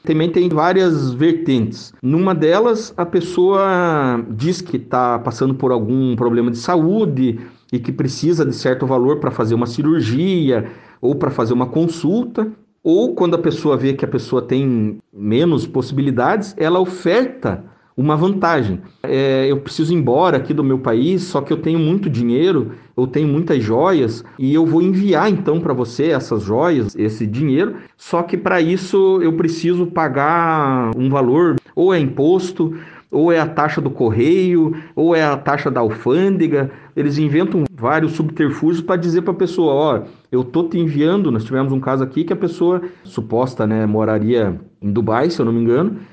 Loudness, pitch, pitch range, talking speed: -17 LUFS, 150 Hz, 130-175 Hz, 175 wpm